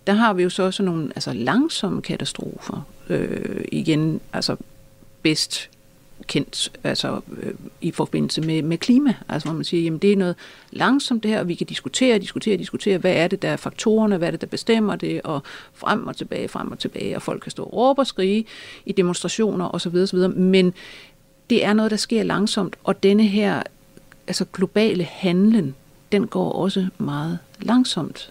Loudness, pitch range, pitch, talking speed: -21 LUFS, 170-210 Hz, 190 Hz, 185 wpm